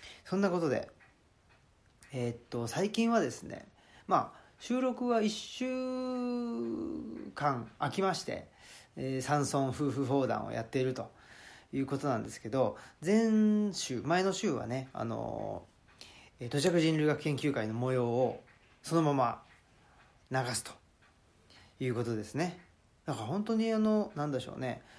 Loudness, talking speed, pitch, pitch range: -33 LUFS, 245 characters per minute, 140 Hz, 120-190 Hz